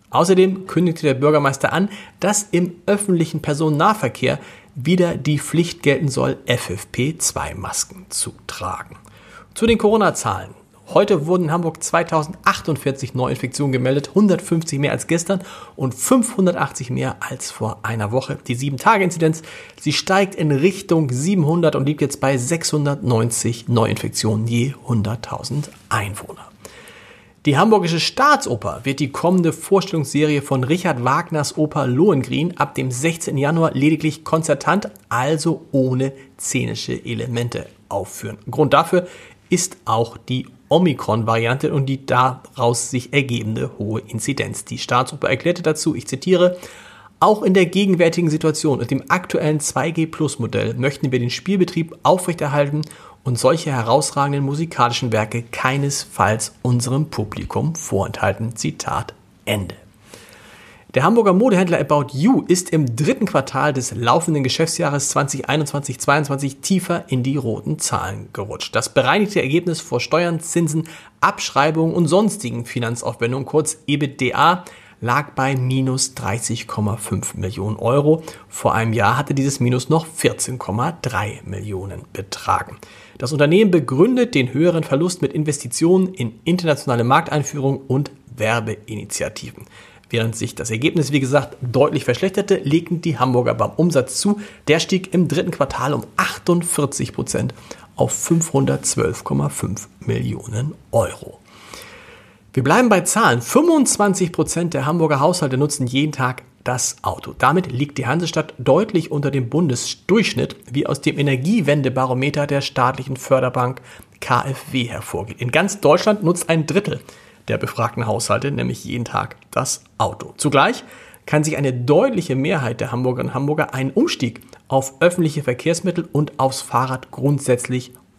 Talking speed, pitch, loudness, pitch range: 125 wpm, 145 Hz, -19 LUFS, 125-165 Hz